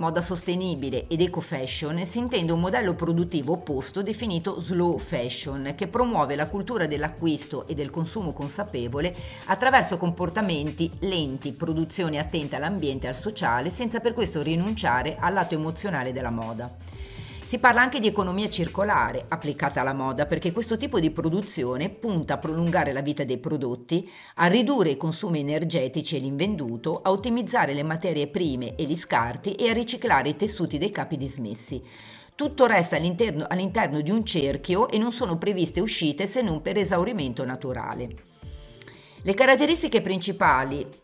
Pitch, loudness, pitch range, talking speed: 165 Hz, -25 LUFS, 145-195 Hz, 155 wpm